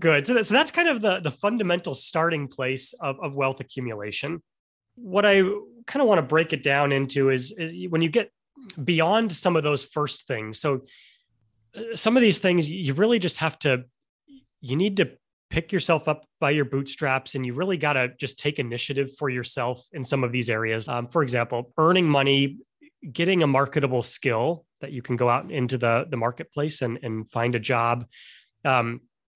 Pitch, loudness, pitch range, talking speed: 145 Hz, -24 LUFS, 130-175 Hz, 195 wpm